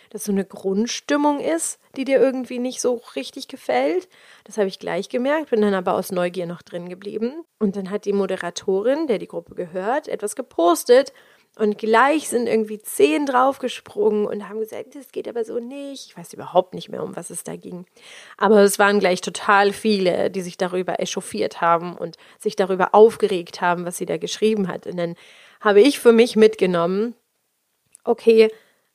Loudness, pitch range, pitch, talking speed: -20 LUFS, 190-250 Hz, 215 Hz, 185 wpm